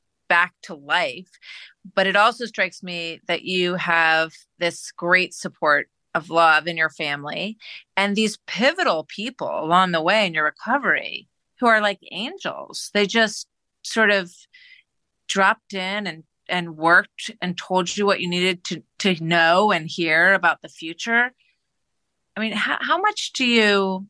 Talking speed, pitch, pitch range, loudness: 155 wpm, 190 Hz, 170-220 Hz, -20 LUFS